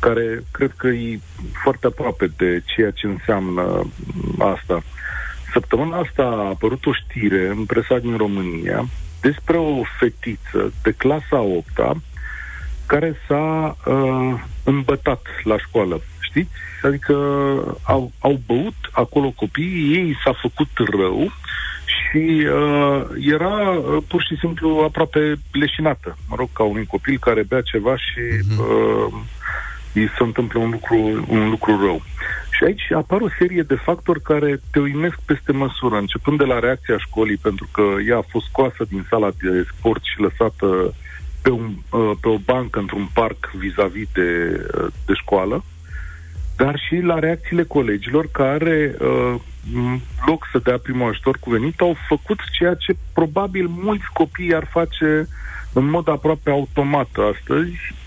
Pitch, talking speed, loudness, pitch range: 125 Hz, 145 wpm, -20 LUFS, 105-150 Hz